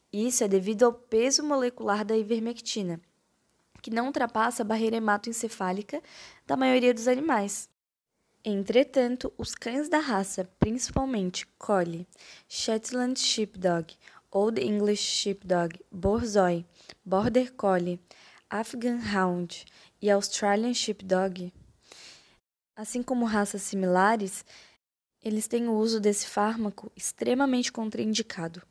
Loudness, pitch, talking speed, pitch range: -28 LUFS, 215 Hz, 105 wpm, 195-240 Hz